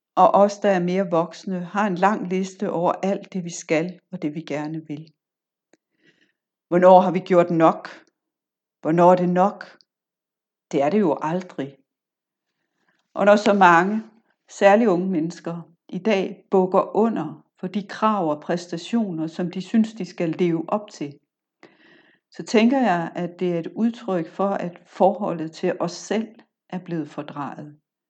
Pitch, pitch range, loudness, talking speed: 180 Hz, 165-200 Hz, -21 LUFS, 160 wpm